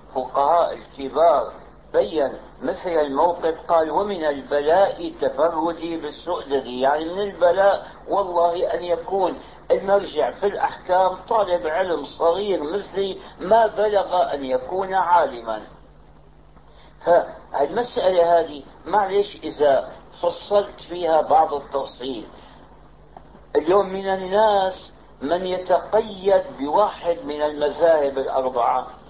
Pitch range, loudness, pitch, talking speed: 150-200 Hz, -21 LUFS, 175 Hz, 95 wpm